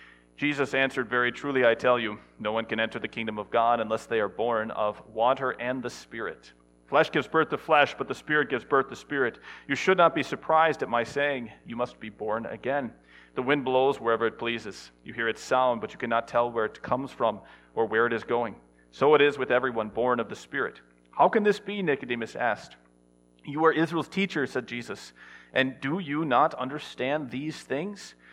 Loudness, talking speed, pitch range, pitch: -27 LUFS, 210 wpm, 110-145 Hz, 120 Hz